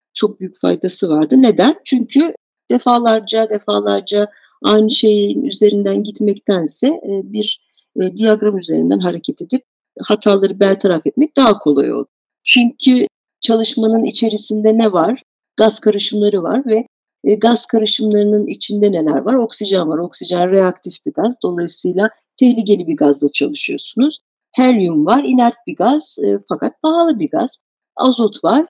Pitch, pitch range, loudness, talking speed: 215 Hz, 195-250 Hz, -15 LUFS, 125 wpm